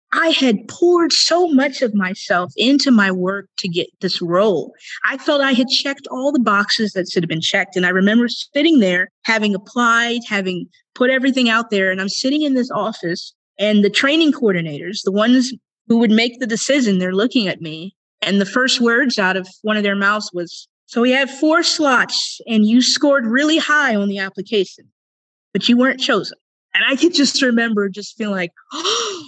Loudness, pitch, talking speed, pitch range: -16 LUFS, 230 Hz, 200 wpm, 195-270 Hz